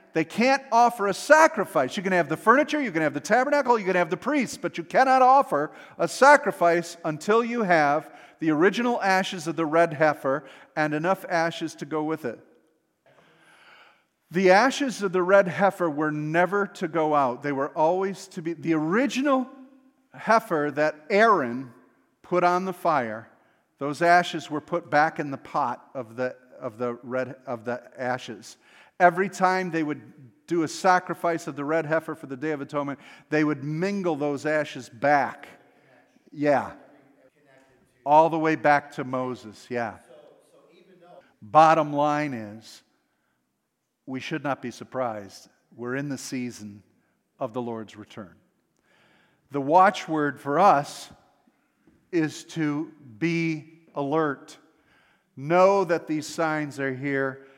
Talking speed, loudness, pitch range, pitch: 150 wpm, -24 LUFS, 140-185 Hz, 155 Hz